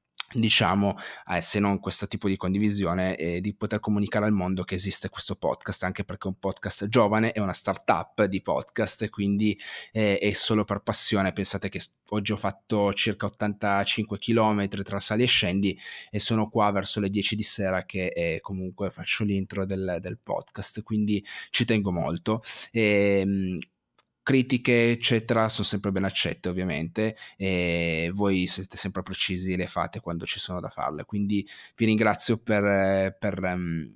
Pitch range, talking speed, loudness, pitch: 95-105 Hz, 170 wpm, -26 LUFS, 100 Hz